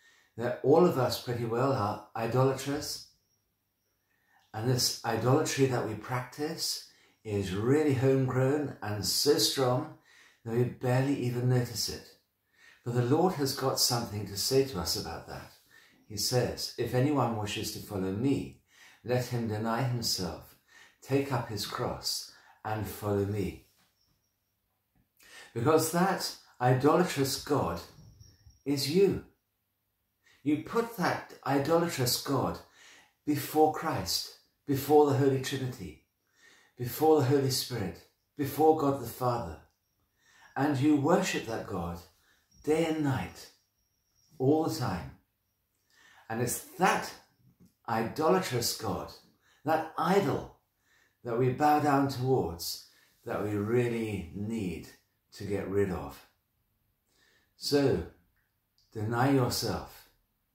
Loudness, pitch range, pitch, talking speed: -30 LUFS, 100-140 Hz, 120 Hz, 115 wpm